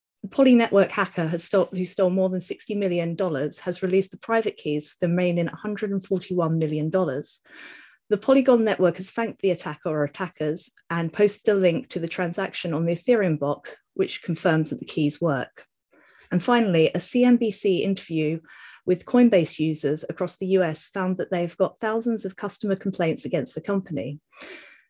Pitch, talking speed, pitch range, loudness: 180 Hz, 170 wpm, 165-200 Hz, -24 LUFS